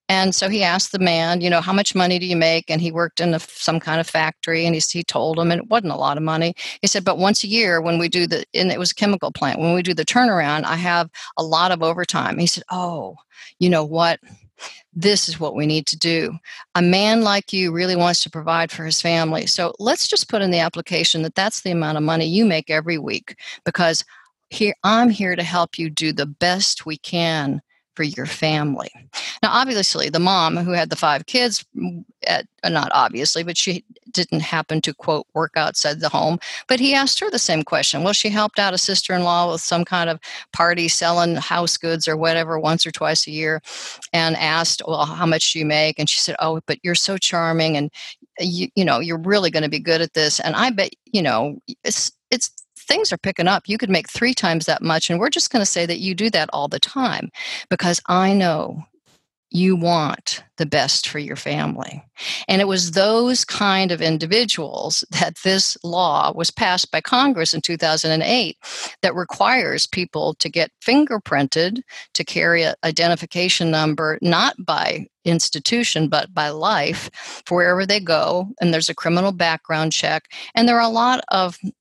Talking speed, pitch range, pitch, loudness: 210 wpm, 160-195 Hz, 170 Hz, -19 LUFS